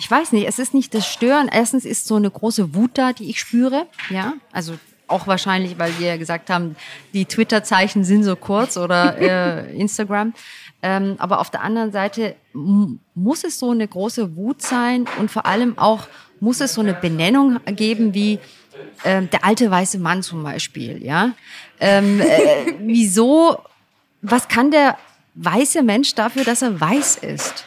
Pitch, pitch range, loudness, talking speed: 215 Hz, 190-245 Hz, -18 LUFS, 175 wpm